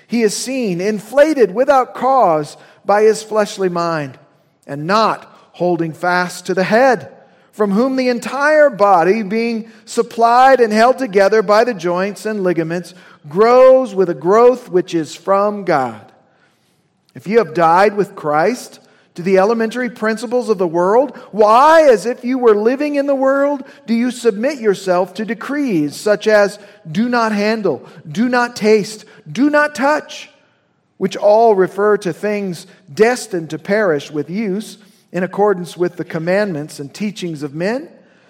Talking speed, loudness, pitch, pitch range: 155 wpm, -15 LUFS, 210 Hz, 180-235 Hz